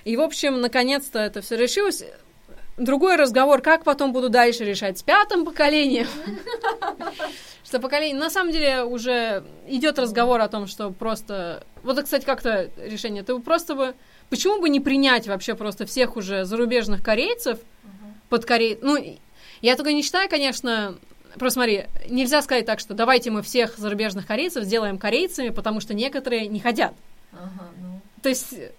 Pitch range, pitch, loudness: 220-290 Hz, 250 Hz, -22 LUFS